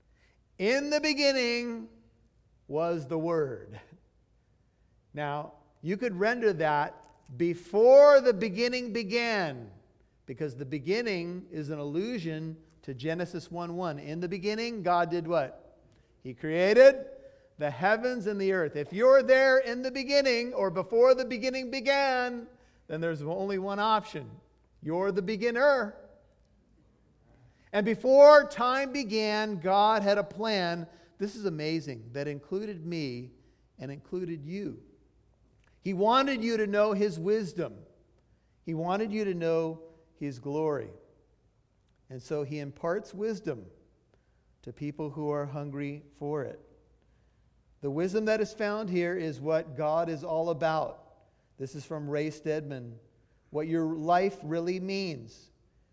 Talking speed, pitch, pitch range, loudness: 130 wpm, 175 Hz, 150-220 Hz, -28 LUFS